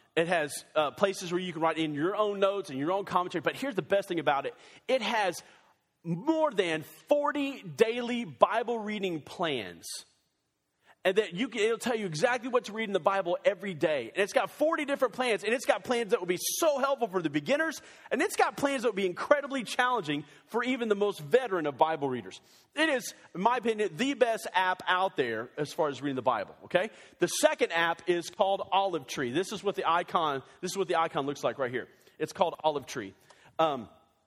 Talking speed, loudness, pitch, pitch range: 220 wpm, -30 LUFS, 195 Hz, 165-245 Hz